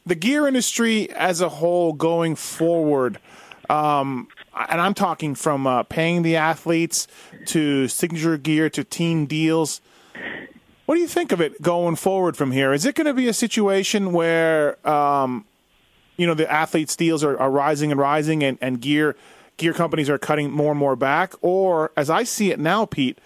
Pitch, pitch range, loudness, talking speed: 160 Hz, 145-180 Hz, -20 LUFS, 180 wpm